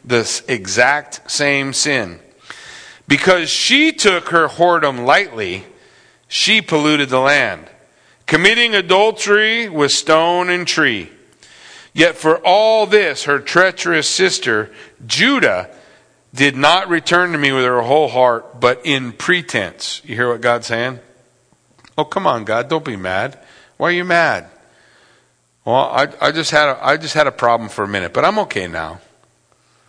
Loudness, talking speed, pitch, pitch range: -14 LUFS, 150 wpm, 155 Hz, 125-180 Hz